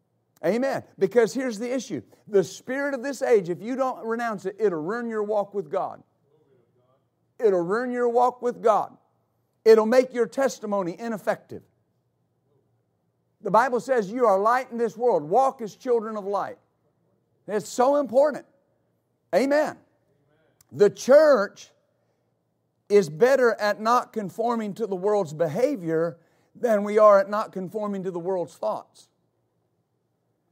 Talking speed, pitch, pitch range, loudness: 140 wpm, 220 Hz, 190-245 Hz, -24 LUFS